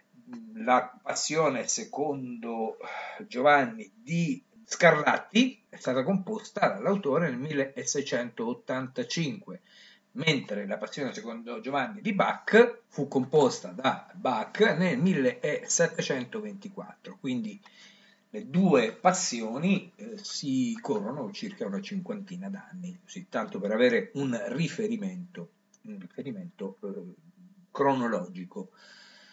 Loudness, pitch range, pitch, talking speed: -28 LUFS, 170-225 Hz, 200 Hz, 90 wpm